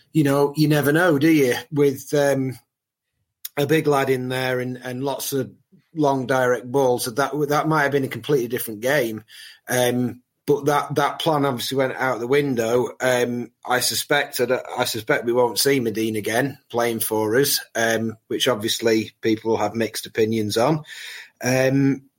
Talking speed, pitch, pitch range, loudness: 170 wpm, 130 Hz, 120-140 Hz, -21 LUFS